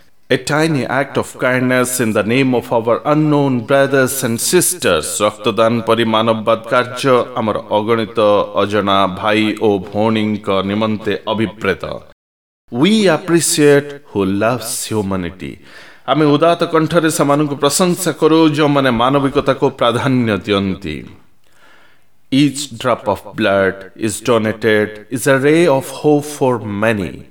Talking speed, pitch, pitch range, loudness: 90 wpm, 120 Hz, 105-145 Hz, -15 LUFS